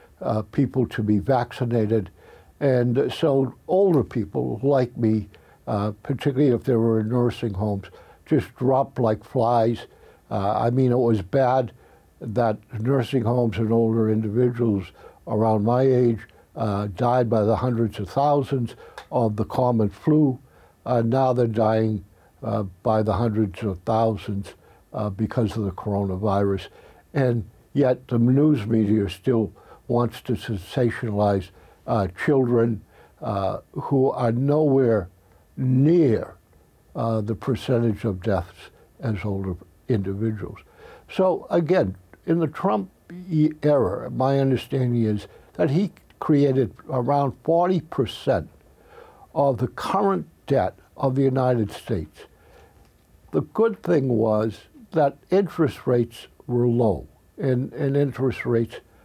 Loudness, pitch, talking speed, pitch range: -23 LUFS, 120 Hz, 125 wpm, 110-135 Hz